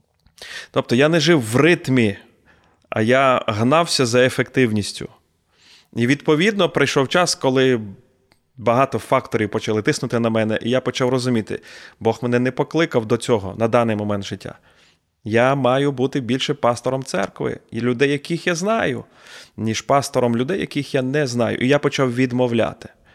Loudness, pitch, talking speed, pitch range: -19 LUFS, 125 Hz, 150 wpm, 110-140 Hz